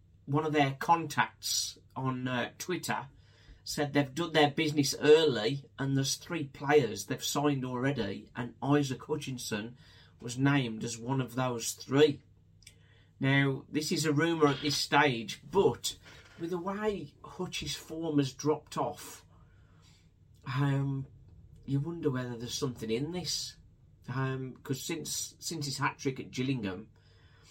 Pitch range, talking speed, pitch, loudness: 120-150 Hz, 140 wpm, 135 Hz, -31 LUFS